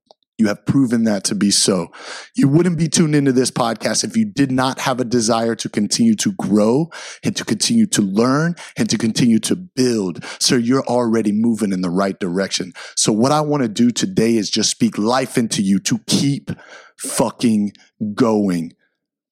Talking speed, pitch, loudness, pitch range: 185 wpm, 120 Hz, -17 LUFS, 110-150 Hz